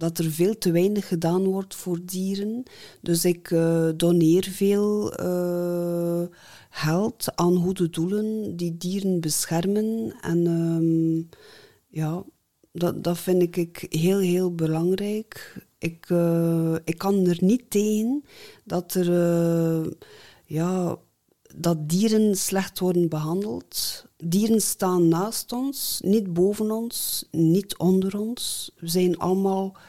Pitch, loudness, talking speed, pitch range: 180 Hz, -24 LUFS, 120 wpm, 170-195 Hz